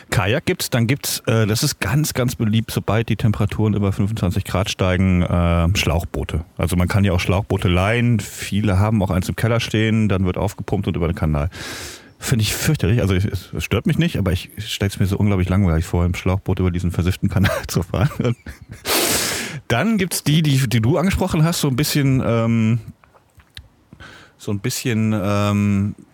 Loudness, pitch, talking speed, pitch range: -19 LUFS, 105 Hz, 195 wpm, 95-120 Hz